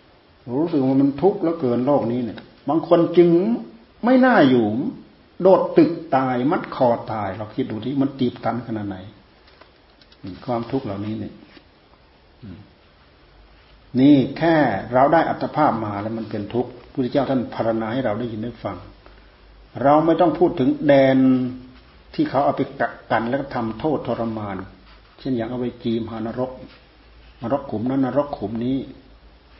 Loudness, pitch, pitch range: -20 LUFS, 125 Hz, 110-140 Hz